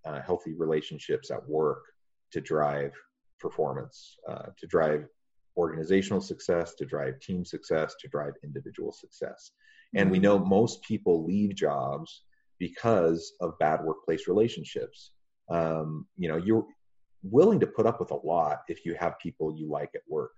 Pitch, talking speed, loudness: 95 Hz, 155 wpm, -29 LUFS